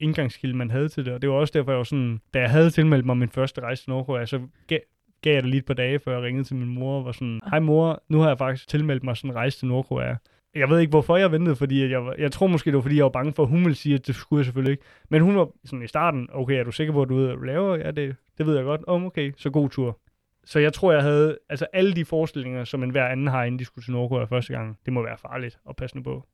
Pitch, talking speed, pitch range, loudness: 135 Hz, 310 wpm, 125-155 Hz, -23 LUFS